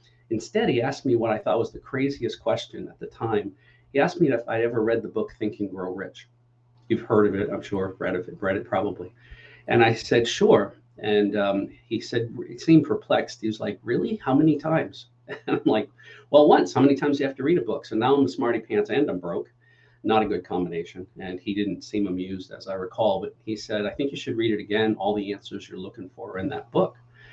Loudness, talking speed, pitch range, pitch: -24 LUFS, 245 wpm, 100-120 Hz, 110 Hz